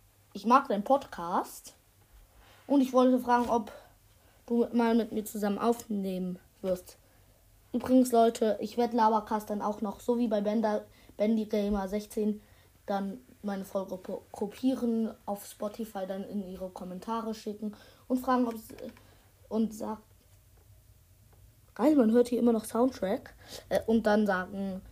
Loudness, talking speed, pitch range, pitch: -30 LUFS, 140 wpm, 195-235 Hz, 215 Hz